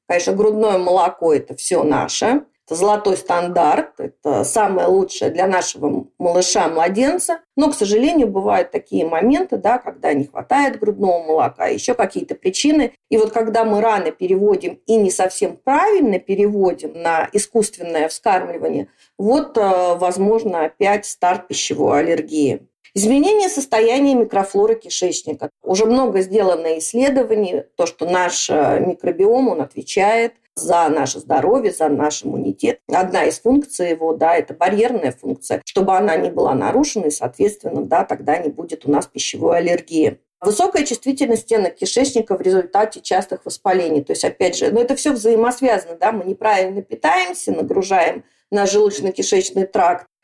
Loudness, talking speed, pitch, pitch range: -17 LUFS, 140 wpm, 205 Hz, 175-240 Hz